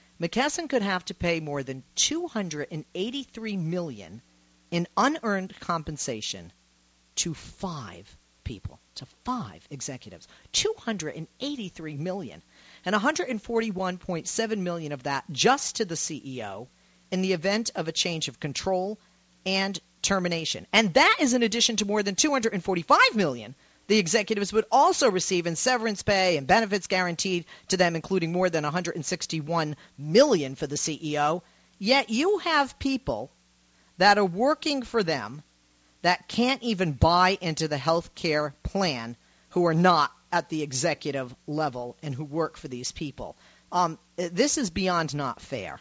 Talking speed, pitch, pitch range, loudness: 140 wpm, 175 Hz, 150-210 Hz, -26 LUFS